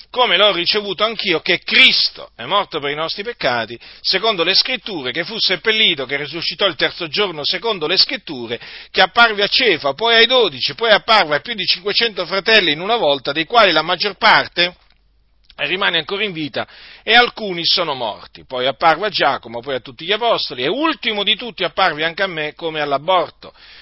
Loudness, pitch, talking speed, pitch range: -15 LUFS, 190 Hz, 190 wpm, 160-220 Hz